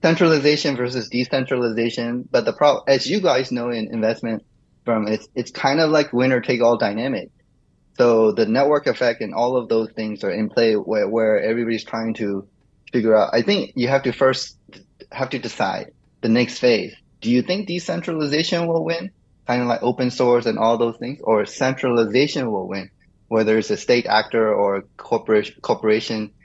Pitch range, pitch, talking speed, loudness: 110-135 Hz, 120 Hz, 180 wpm, -20 LUFS